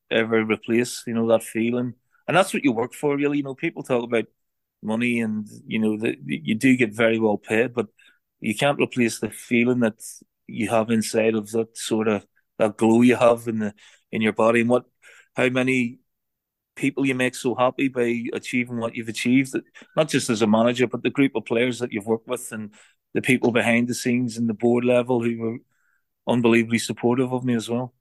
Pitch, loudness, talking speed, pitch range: 120 Hz, -22 LUFS, 210 wpm, 115-125 Hz